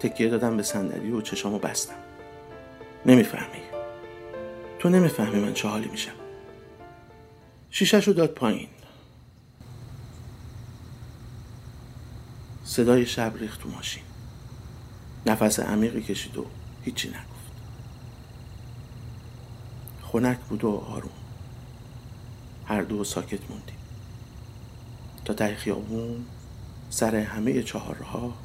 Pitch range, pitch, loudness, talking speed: 110-120 Hz, 115 Hz, -26 LUFS, 90 wpm